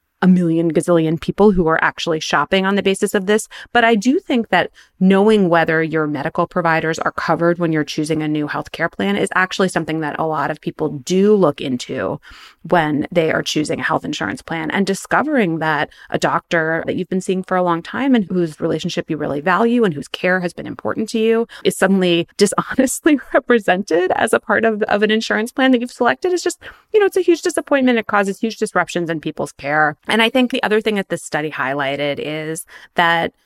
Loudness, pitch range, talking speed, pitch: -17 LUFS, 160-220 Hz, 215 wpm, 180 Hz